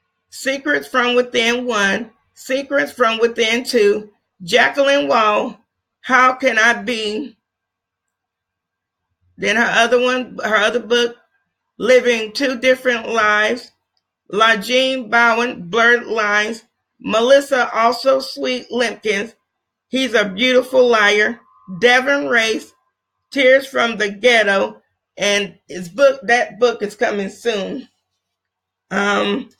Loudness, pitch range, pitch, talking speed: -16 LUFS, 200-250 Hz, 230 Hz, 105 wpm